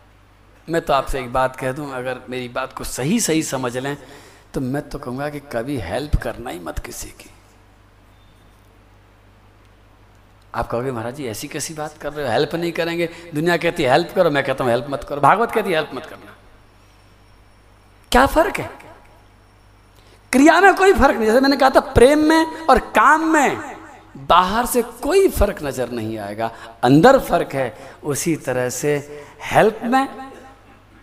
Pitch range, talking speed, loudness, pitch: 105-170 Hz, 170 wpm, -18 LUFS, 135 Hz